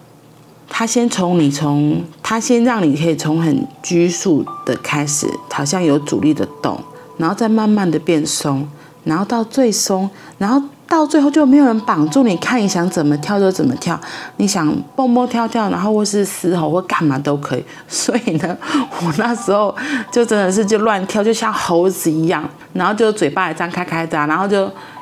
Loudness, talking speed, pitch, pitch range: -16 LUFS, 265 characters per minute, 190 Hz, 155-230 Hz